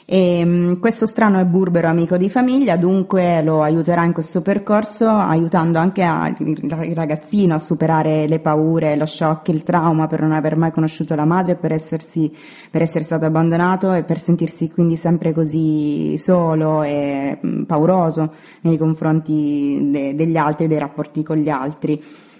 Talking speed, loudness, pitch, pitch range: 160 wpm, -17 LUFS, 160 Hz, 155-175 Hz